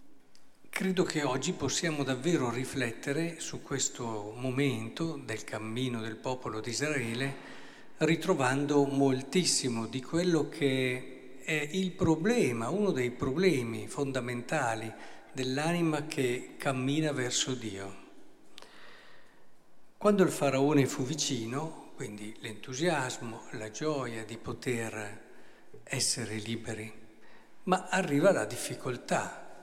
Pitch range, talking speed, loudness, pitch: 120-155 Hz, 100 wpm, -31 LUFS, 130 Hz